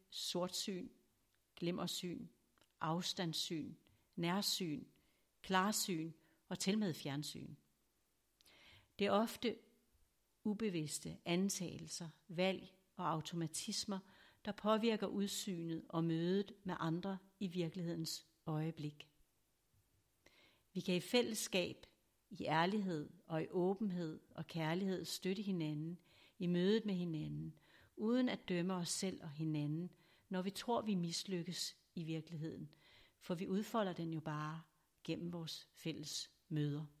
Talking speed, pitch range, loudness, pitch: 110 wpm, 160-195 Hz, -42 LUFS, 175 Hz